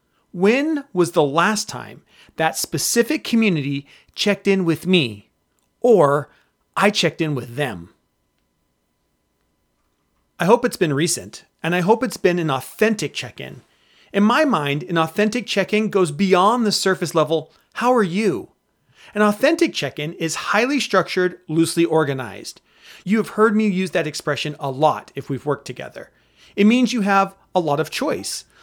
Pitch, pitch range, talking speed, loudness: 180 Hz, 155-215 Hz, 160 wpm, -19 LUFS